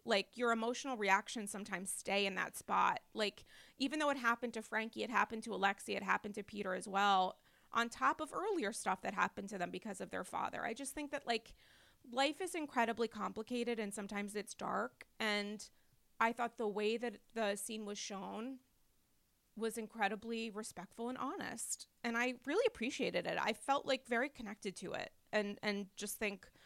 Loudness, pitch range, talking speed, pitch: -39 LUFS, 205-245 Hz, 185 wpm, 225 Hz